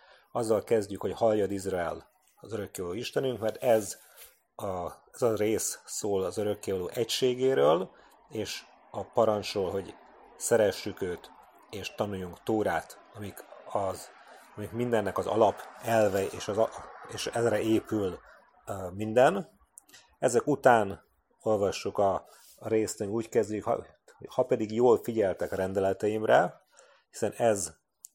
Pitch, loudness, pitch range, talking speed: 105 Hz, -29 LUFS, 100-115 Hz, 120 wpm